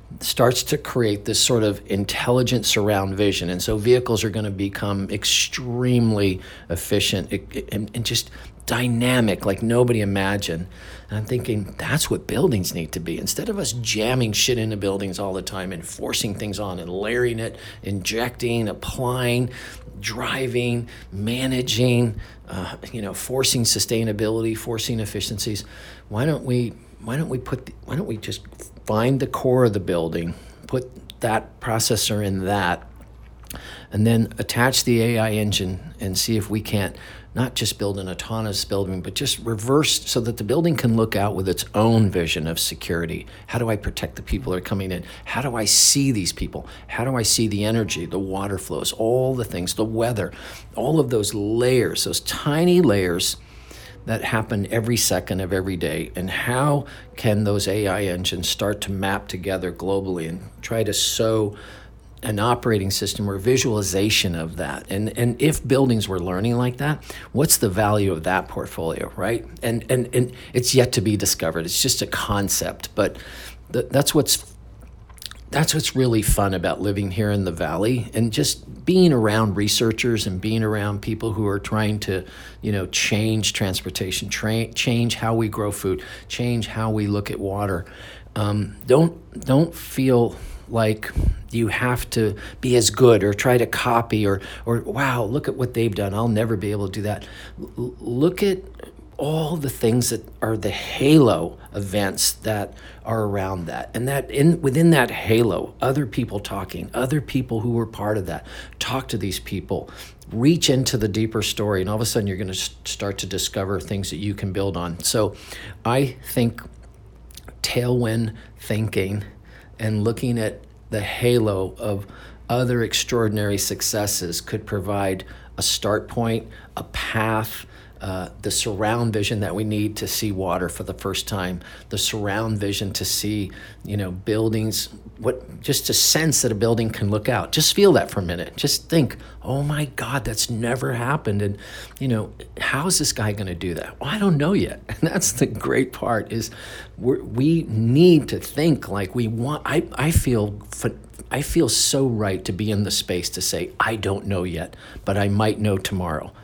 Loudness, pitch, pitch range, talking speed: -22 LUFS, 110 Hz, 100-120 Hz, 175 wpm